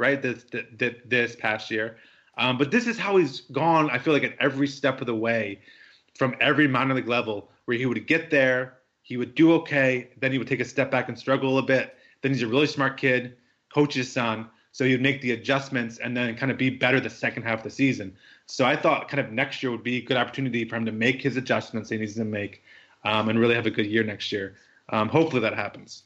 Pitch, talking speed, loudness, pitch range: 125 Hz, 255 wpm, -25 LUFS, 115-135 Hz